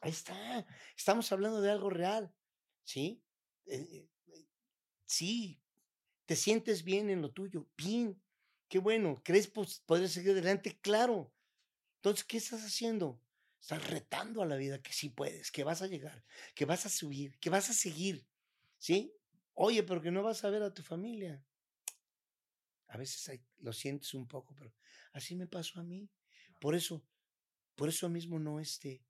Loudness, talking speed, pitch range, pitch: -37 LUFS, 165 wpm, 145-205 Hz, 180 Hz